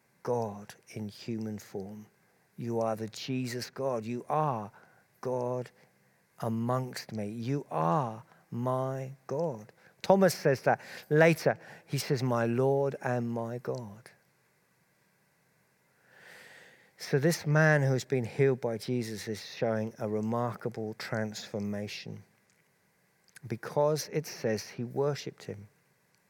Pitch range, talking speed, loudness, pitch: 110-145 Hz, 110 wpm, -31 LUFS, 125 Hz